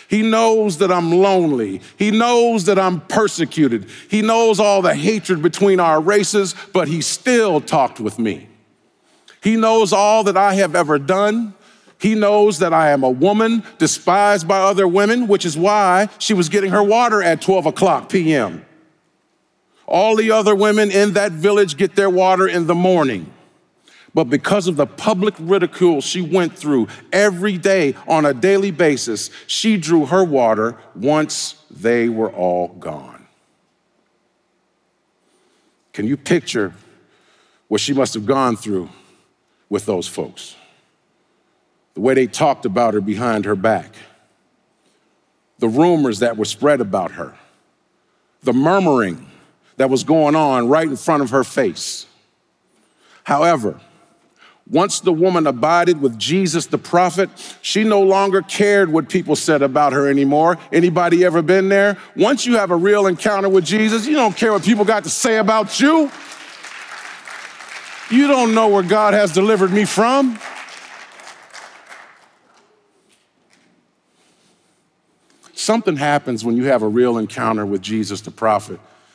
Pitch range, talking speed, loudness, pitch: 150-210 Hz, 145 wpm, -16 LUFS, 190 Hz